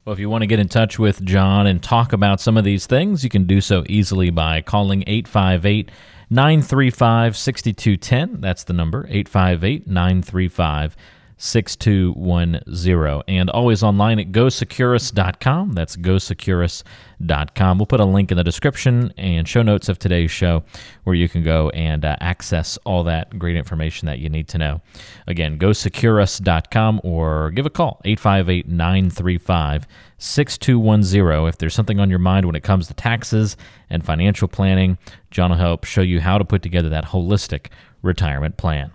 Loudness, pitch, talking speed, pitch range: -18 LUFS, 95 Hz, 155 wpm, 85-110 Hz